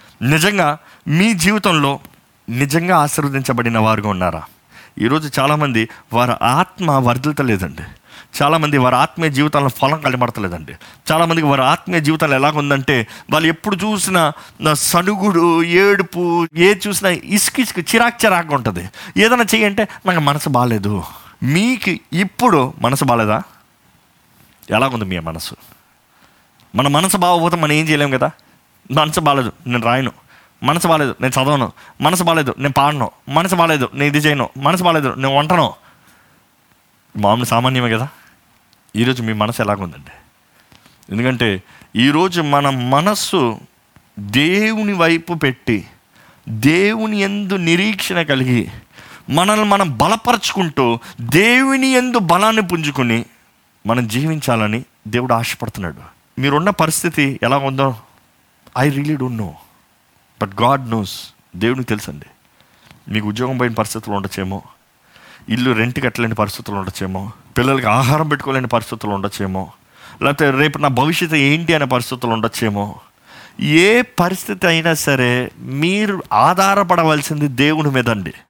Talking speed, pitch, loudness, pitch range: 115 wpm, 140 Hz, -16 LUFS, 120-170 Hz